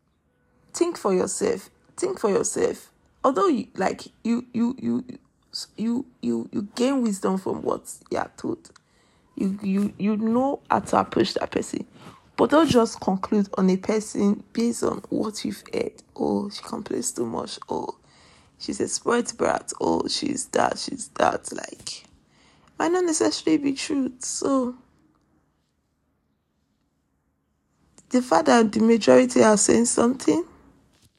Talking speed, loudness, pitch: 140 wpm, -24 LUFS, 225 Hz